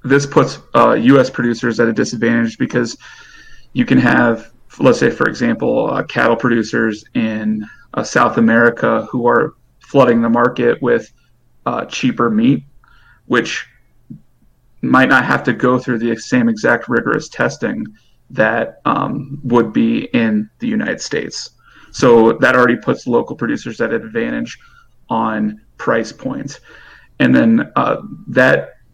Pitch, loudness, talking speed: 120 Hz, -15 LUFS, 140 wpm